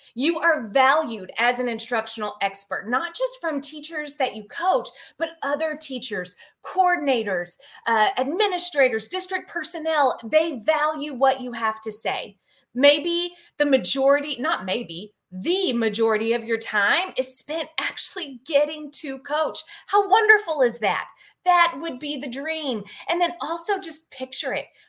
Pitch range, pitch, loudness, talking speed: 245-330 Hz, 285 Hz, -23 LUFS, 145 wpm